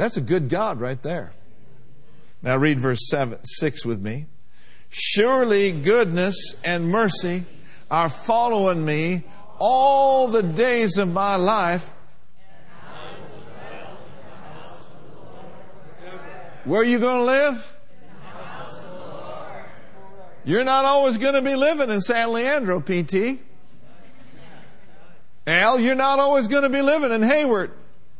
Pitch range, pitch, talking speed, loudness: 165-245 Hz, 195 Hz, 115 wpm, -20 LUFS